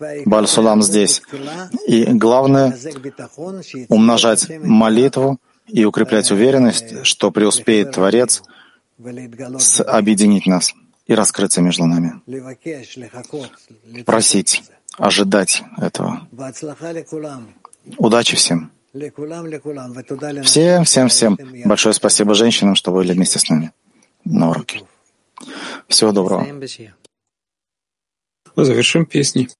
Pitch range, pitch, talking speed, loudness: 105-140 Hz, 120 Hz, 80 wpm, -14 LUFS